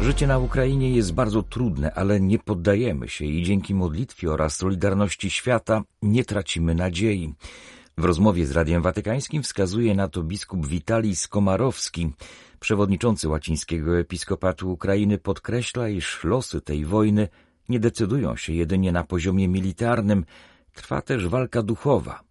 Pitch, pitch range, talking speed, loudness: 95 Hz, 85-110 Hz, 135 wpm, -24 LUFS